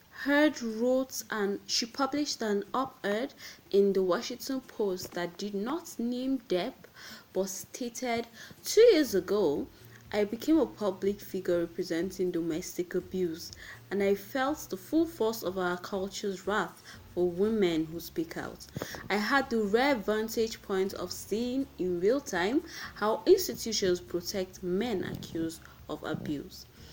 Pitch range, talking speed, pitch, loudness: 180-250 Hz, 140 wpm, 200 Hz, -31 LUFS